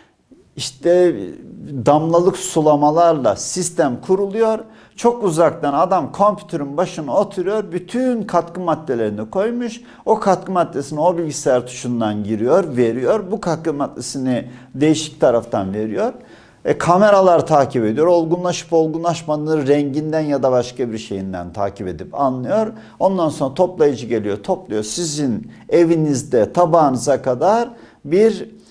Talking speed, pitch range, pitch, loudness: 115 wpm, 130-180 Hz, 160 Hz, -18 LUFS